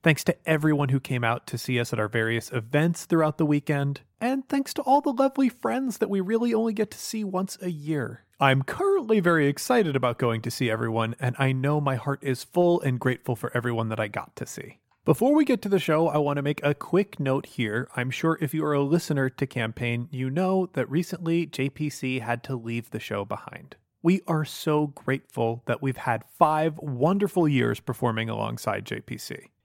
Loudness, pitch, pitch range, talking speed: -26 LUFS, 145 Hz, 125-175 Hz, 215 wpm